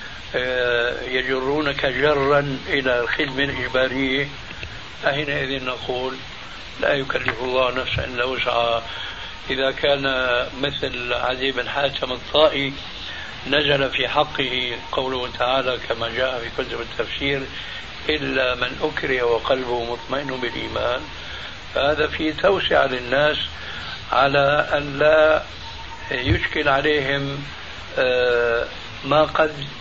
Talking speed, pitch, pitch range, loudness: 95 wpm, 130 Hz, 125-140 Hz, -21 LUFS